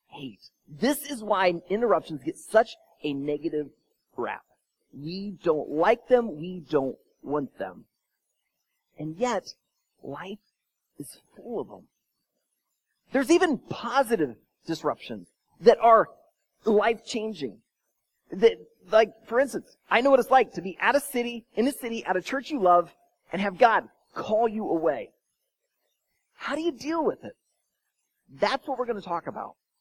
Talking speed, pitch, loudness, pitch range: 145 wpm, 225 Hz, -26 LUFS, 175-275 Hz